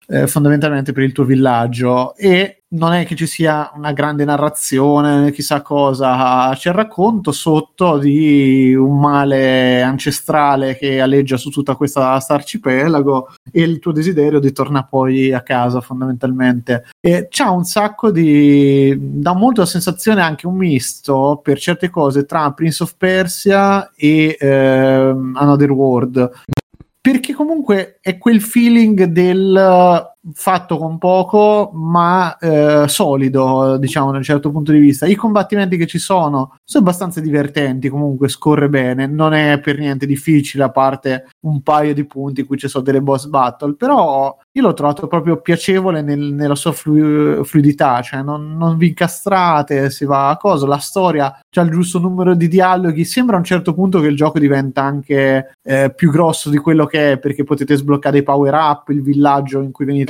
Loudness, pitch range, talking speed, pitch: -14 LUFS, 135-175 Hz, 170 wpm, 145 Hz